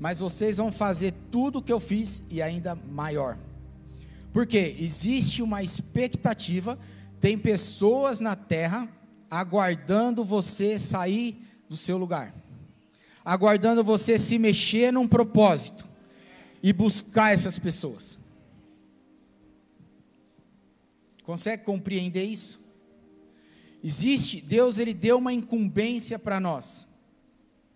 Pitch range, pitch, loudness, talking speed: 170-225 Hz, 205 Hz, -25 LUFS, 100 wpm